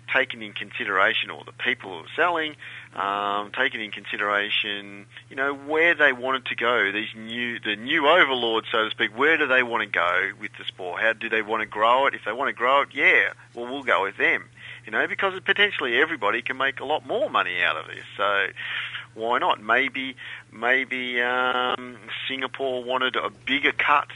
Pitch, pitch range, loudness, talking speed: 125 Hz, 110-130 Hz, -23 LUFS, 200 wpm